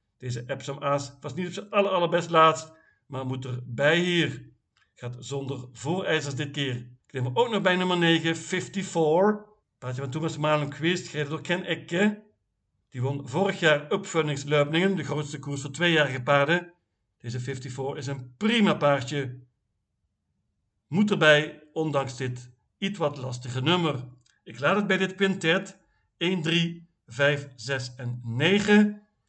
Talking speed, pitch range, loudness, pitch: 150 wpm, 130-175 Hz, -26 LUFS, 150 Hz